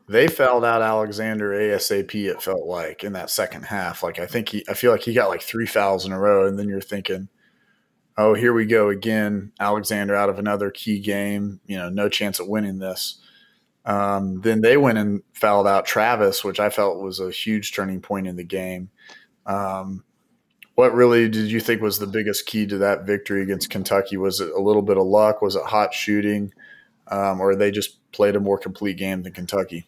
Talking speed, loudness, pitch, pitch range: 210 wpm, -21 LUFS, 100 Hz, 95-105 Hz